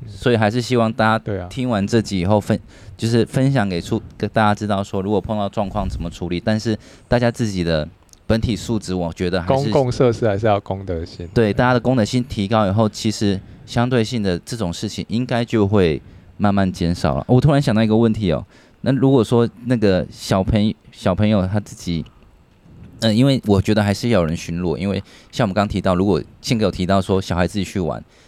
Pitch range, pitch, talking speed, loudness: 95-115 Hz, 105 Hz, 325 characters per minute, -19 LUFS